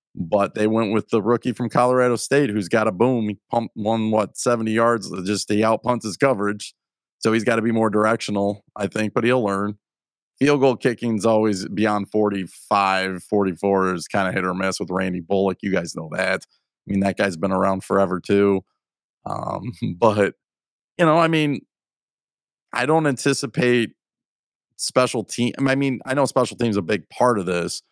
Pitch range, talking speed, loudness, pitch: 100-125 Hz, 185 wpm, -21 LUFS, 110 Hz